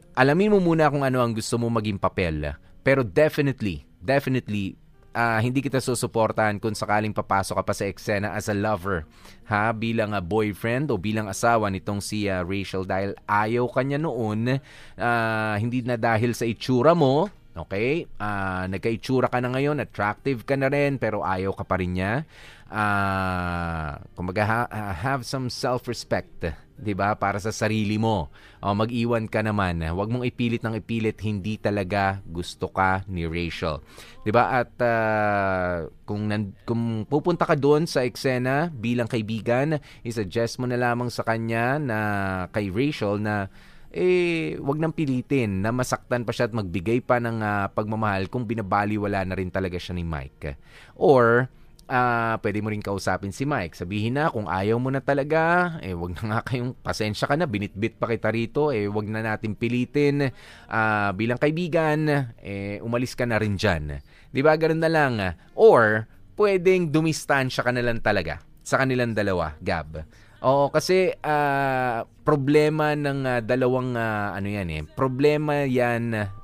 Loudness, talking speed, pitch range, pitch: -24 LUFS, 165 wpm, 100-130 Hz, 115 Hz